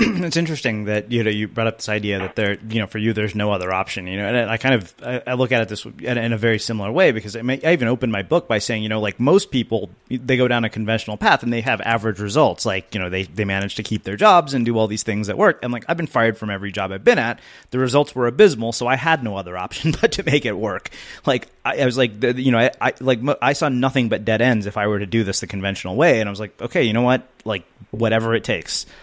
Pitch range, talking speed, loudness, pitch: 105-125 Hz, 295 wpm, -20 LUFS, 115 Hz